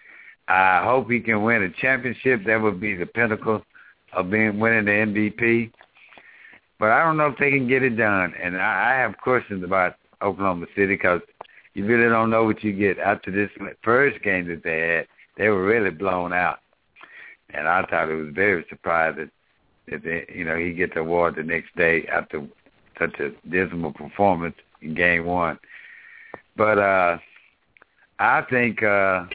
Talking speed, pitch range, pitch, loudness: 175 wpm, 90-115 Hz, 105 Hz, -21 LUFS